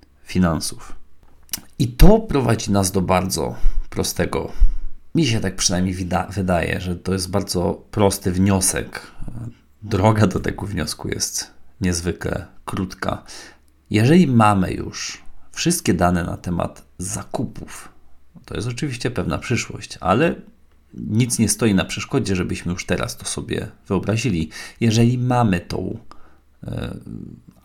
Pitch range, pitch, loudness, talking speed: 90-110 Hz, 95 Hz, -21 LUFS, 120 wpm